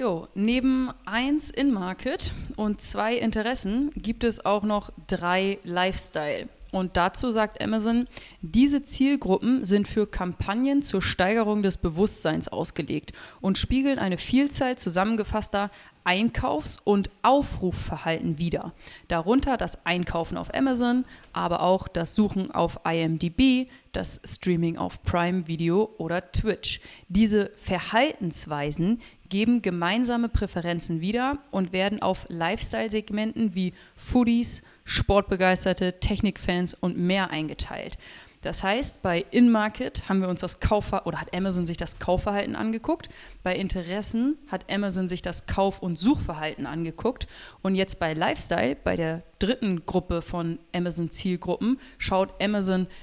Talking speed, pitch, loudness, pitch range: 125 wpm, 195 Hz, -26 LUFS, 180-230 Hz